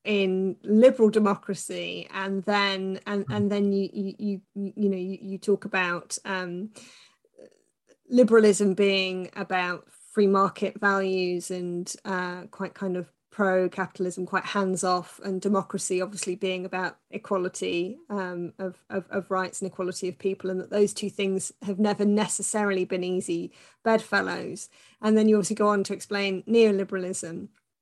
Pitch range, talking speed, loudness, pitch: 185-205 Hz, 145 wpm, -26 LUFS, 195 Hz